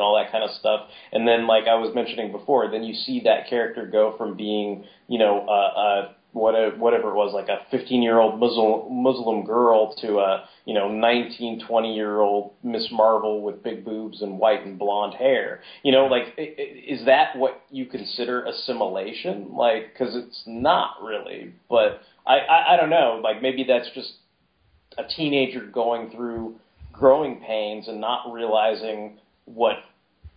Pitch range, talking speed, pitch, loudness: 105-125 Hz, 180 wpm, 115 Hz, -22 LUFS